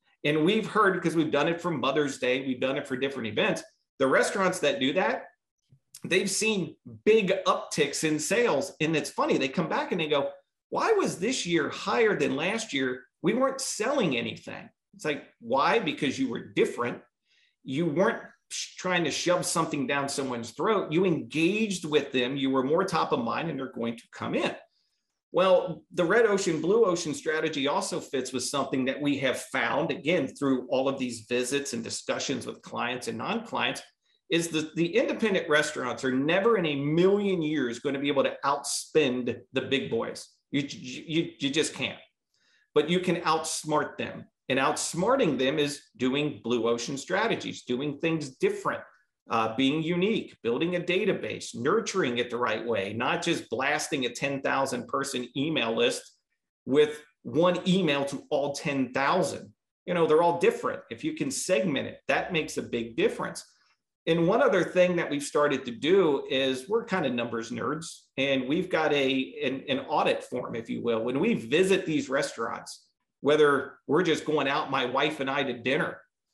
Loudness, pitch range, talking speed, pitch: -27 LUFS, 135-180 Hz, 180 wpm, 150 Hz